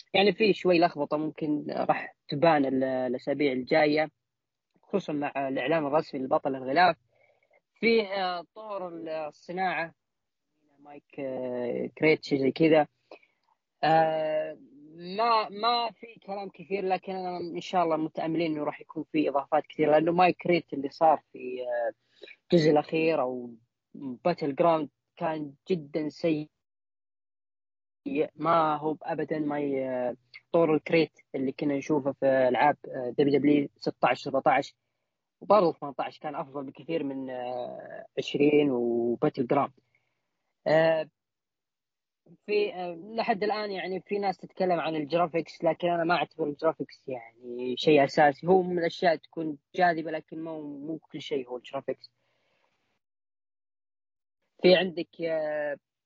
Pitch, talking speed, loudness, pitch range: 155 Hz, 115 wpm, -28 LUFS, 135-170 Hz